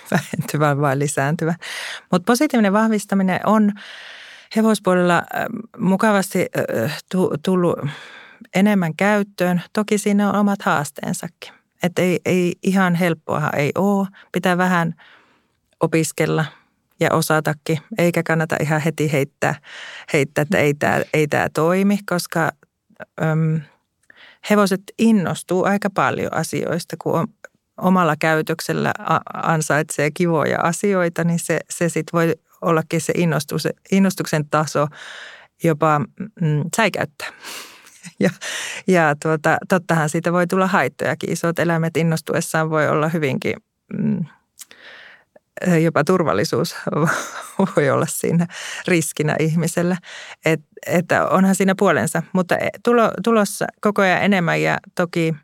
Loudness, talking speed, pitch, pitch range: -19 LUFS, 110 wpm, 175 Hz, 160-195 Hz